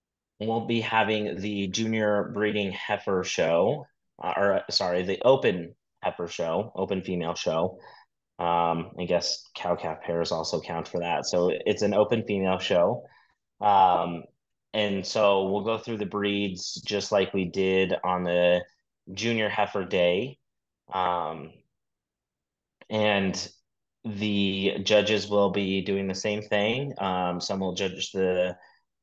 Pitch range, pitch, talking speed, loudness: 90-105 Hz, 95 Hz, 135 wpm, -26 LUFS